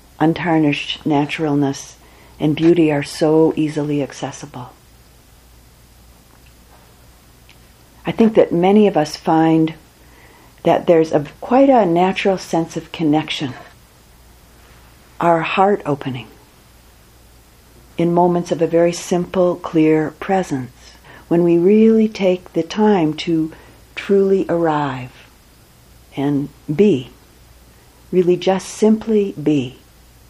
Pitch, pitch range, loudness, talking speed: 155 Hz, 130-175 Hz, -16 LUFS, 100 wpm